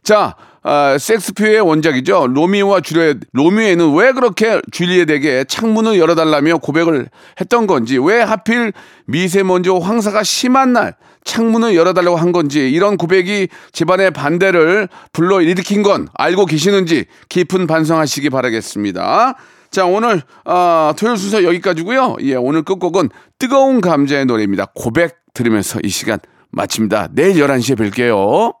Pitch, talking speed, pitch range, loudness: 175 Hz, 330 characters per minute, 150-210 Hz, -13 LUFS